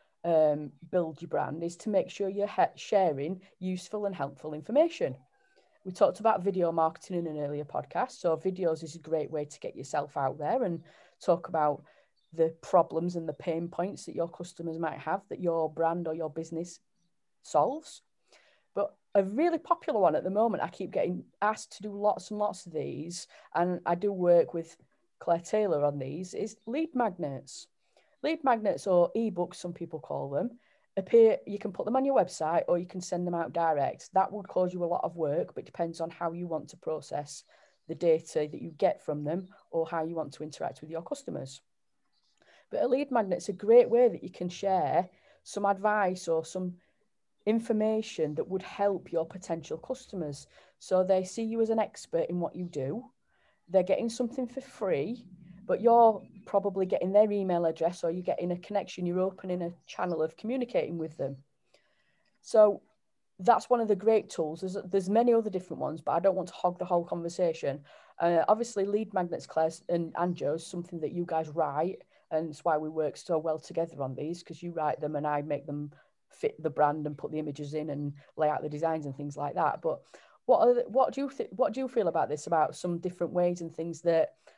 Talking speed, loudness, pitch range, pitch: 205 wpm, -30 LUFS, 160-205 Hz, 175 Hz